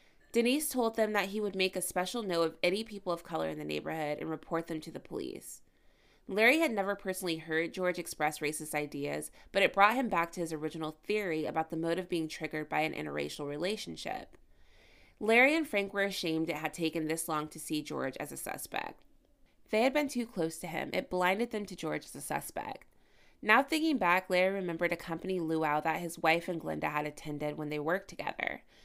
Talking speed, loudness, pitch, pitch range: 210 wpm, -33 LUFS, 170 Hz, 155-200 Hz